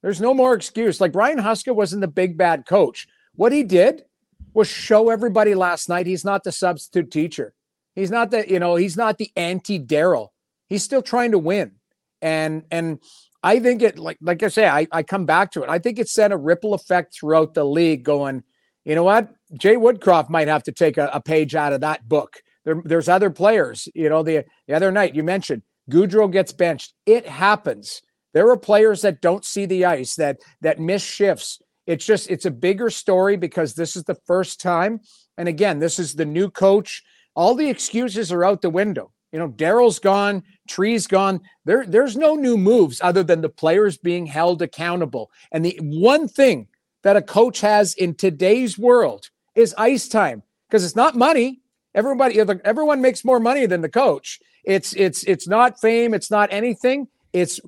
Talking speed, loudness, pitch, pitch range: 200 wpm, -19 LUFS, 195 Hz, 165-220 Hz